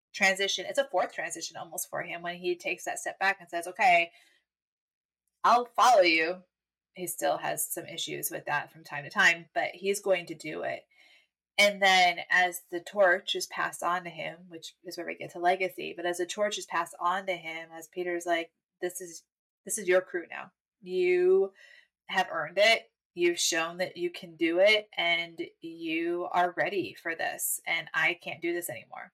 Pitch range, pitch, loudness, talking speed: 175-240 Hz, 180 Hz, -28 LUFS, 200 wpm